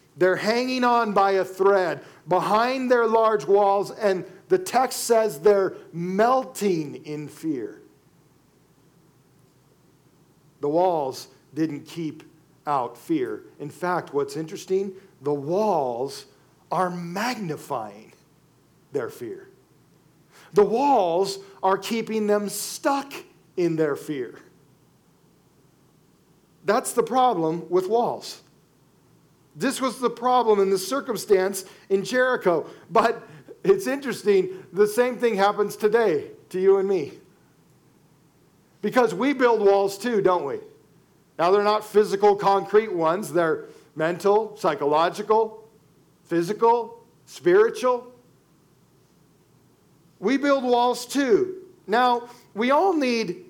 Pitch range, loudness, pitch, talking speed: 180-250 Hz, -23 LUFS, 205 Hz, 105 wpm